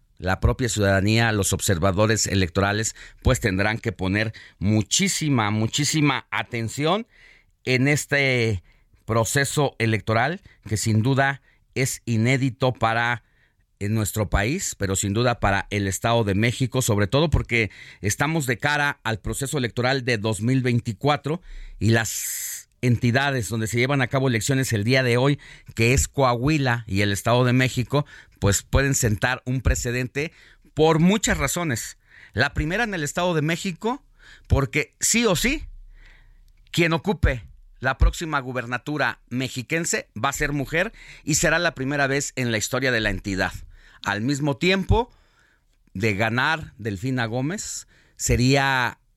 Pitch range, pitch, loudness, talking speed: 110-140 Hz, 125 Hz, -23 LUFS, 140 wpm